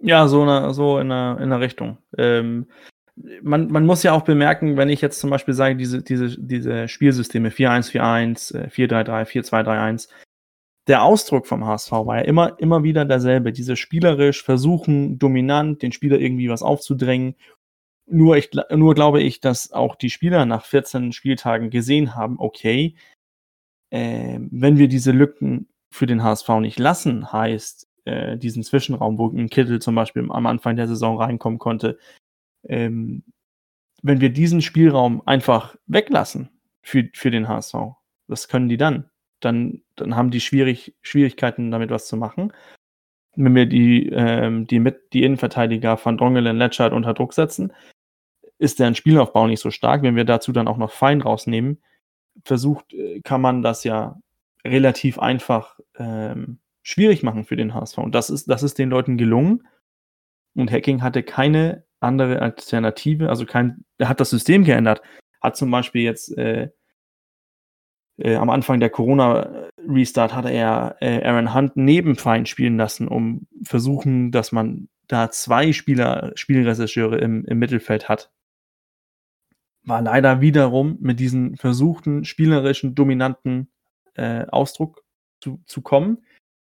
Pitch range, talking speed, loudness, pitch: 115-140 Hz, 150 wpm, -19 LUFS, 125 Hz